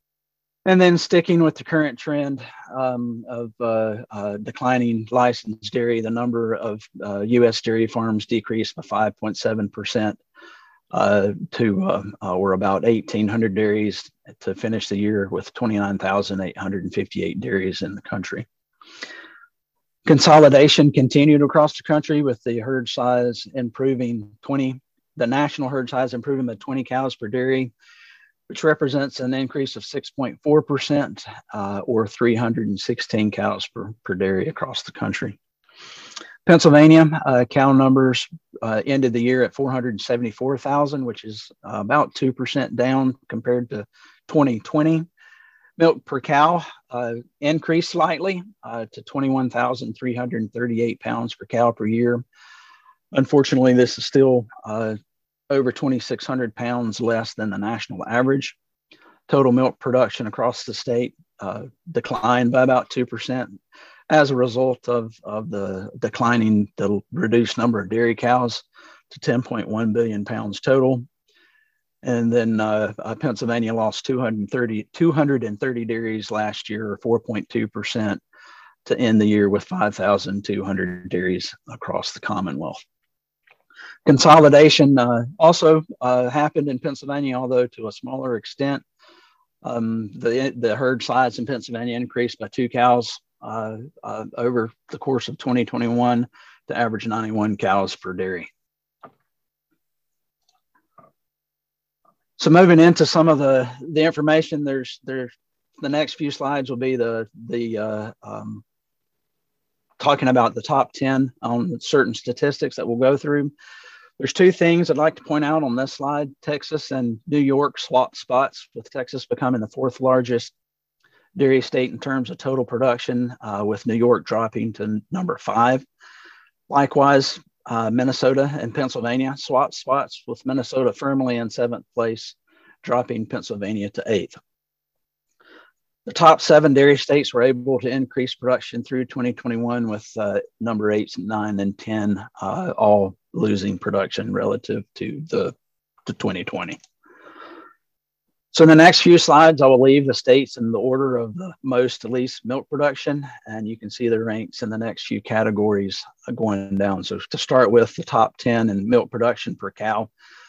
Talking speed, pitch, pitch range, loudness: 140 wpm, 125 Hz, 110-140 Hz, -20 LUFS